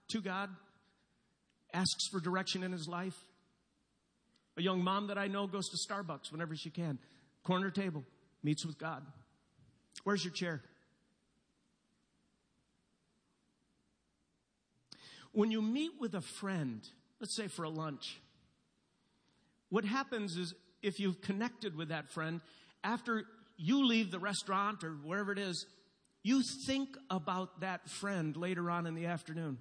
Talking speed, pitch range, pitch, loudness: 135 wpm, 165-200 Hz, 185 Hz, -38 LUFS